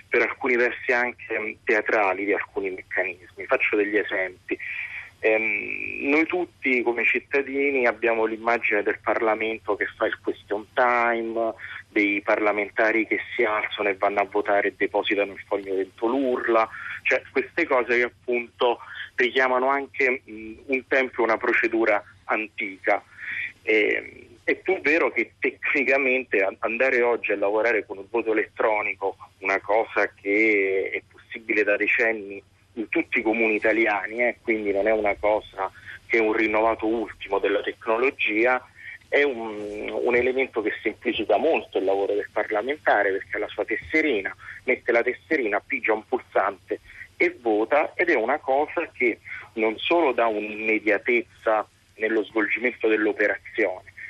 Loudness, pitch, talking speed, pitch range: -23 LUFS, 115 Hz, 140 wpm, 105-130 Hz